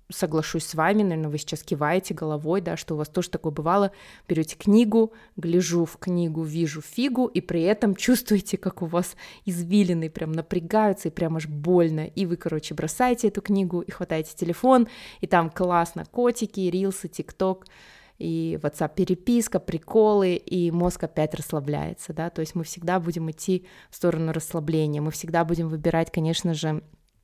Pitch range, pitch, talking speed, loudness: 160-190 Hz, 175 Hz, 165 wpm, -25 LUFS